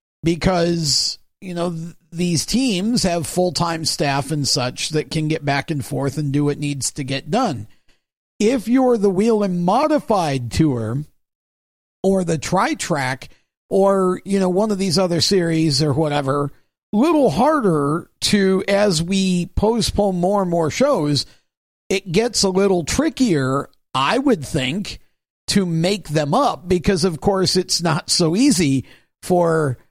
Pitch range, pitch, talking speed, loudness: 150-195 Hz, 175 Hz, 155 wpm, -19 LUFS